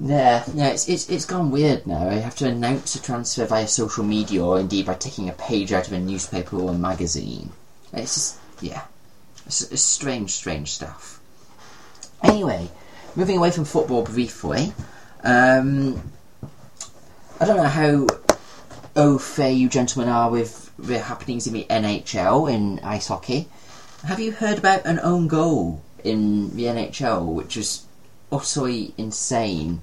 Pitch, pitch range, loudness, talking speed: 120 Hz, 100-140 Hz, -22 LUFS, 155 wpm